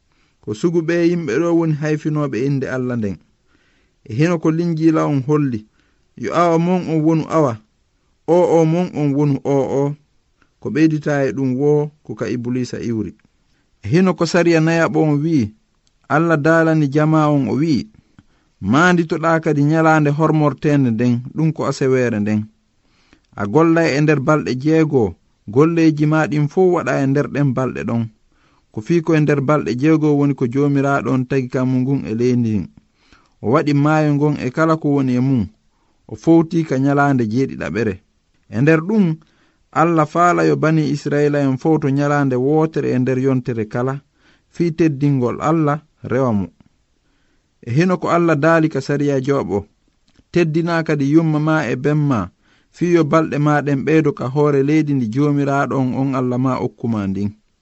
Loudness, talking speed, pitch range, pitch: -17 LUFS, 160 wpm, 130-160 Hz, 145 Hz